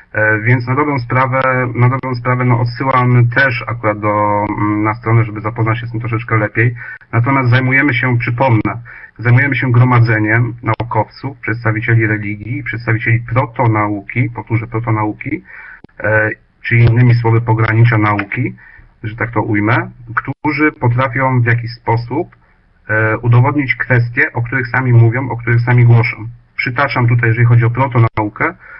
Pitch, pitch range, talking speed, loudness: 120 Hz, 110-125 Hz, 140 wpm, -14 LUFS